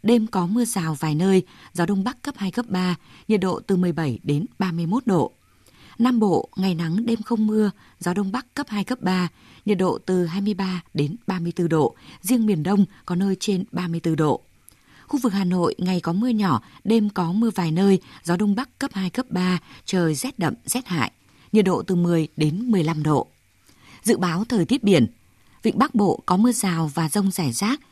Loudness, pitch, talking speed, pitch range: -23 LUFS, 190 Hz, 205 wpm, 170-215 Hz